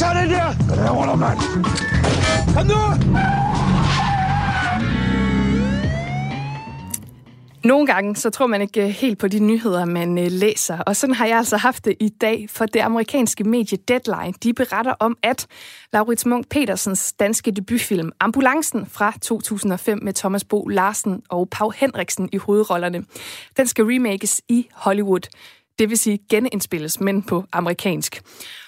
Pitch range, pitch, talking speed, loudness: 185-230 Hz, 210 Hz, 135 wpm, -19 LUFS